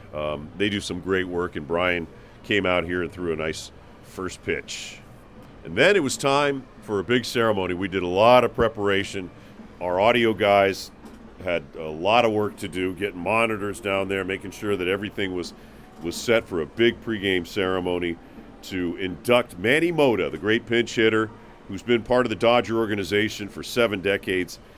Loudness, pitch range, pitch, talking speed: -23 LUFS, 90-115 Hz, 100 Hz, 185 wpm